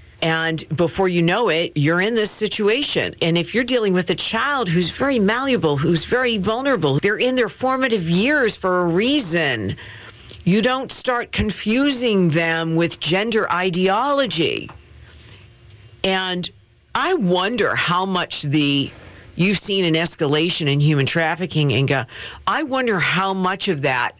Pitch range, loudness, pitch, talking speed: 155-215 Hz, -19 LUFS, 180 Hz, 145 wpm